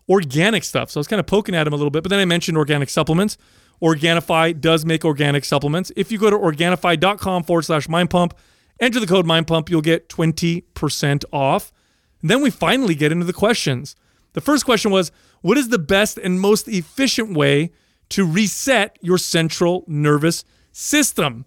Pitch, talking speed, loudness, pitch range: 175 Hz, 190 wpm, -18 LUFS, 160-200 Hz